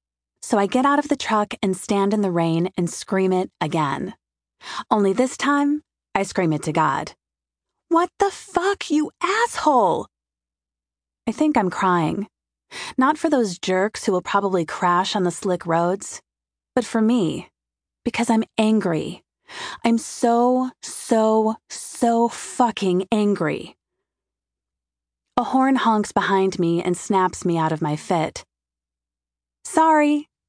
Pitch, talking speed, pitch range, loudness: 200 Hz, 140 wpm, 165-245 Hz, -21 LUFS